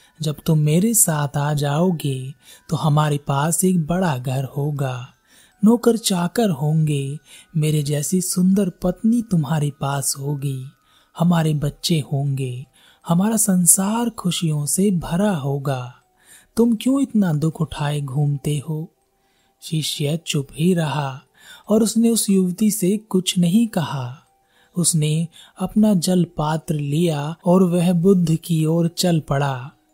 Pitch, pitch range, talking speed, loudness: 160 Hz, 145-185 Hz, 125 wpm, -20 LUFS